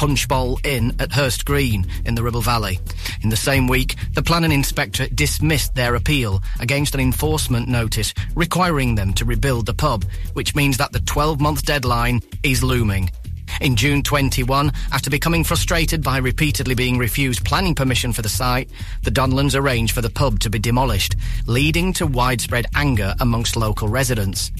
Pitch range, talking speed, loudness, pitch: 110-140 Hz, 165 wpm, -19 LUFS, 125 Hz